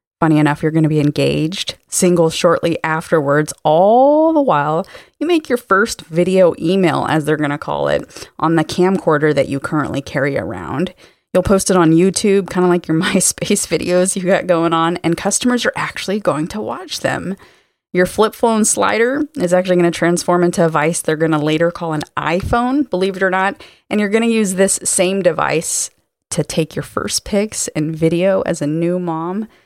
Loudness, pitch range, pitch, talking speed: -16 LUFS, 160-195 Hz, 175 Hz, 200 wpm